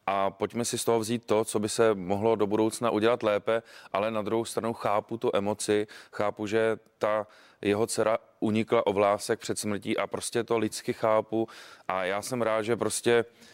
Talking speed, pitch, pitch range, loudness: 190 wpm, 110 Hz, 105-115 Hz, -28 LUFS